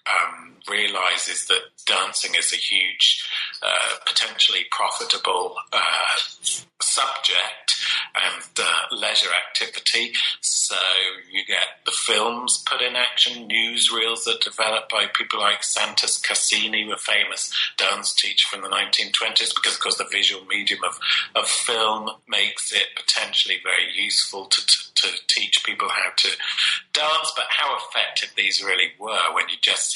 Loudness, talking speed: -20 LUFS, 140 wpm